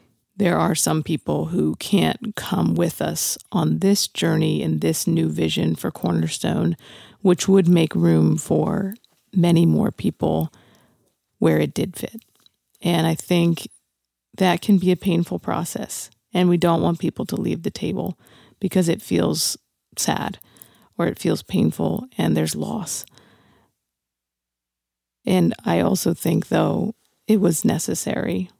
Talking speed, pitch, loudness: 140 wpm, 165 Hz, -21 LUFS